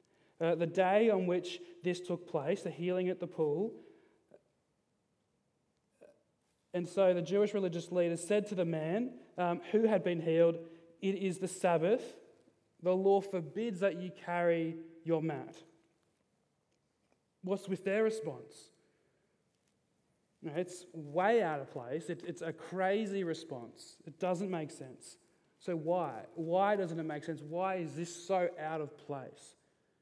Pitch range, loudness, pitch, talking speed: 165-195 Hz, -35 LUFS, 180 Hz, 145 wpm